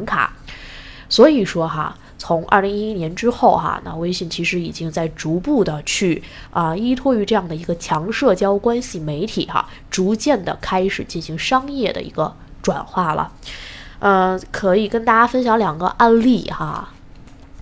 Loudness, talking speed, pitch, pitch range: -18 LUFS, 245 characters per minute, 190 Hz, 170-225 Hz